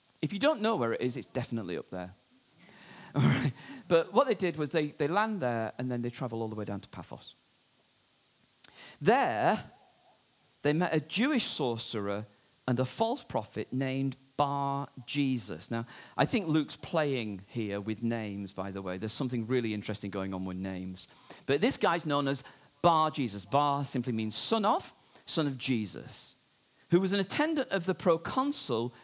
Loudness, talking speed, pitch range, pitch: -31 LUFS, 180 wpm, 110-160 Hz, 130 Hz